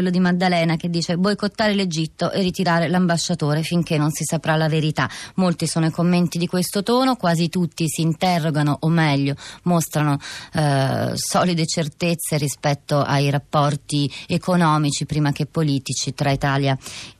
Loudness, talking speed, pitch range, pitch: -20 LUFS, 155 wpm, 145-175 Hz, 160 Hz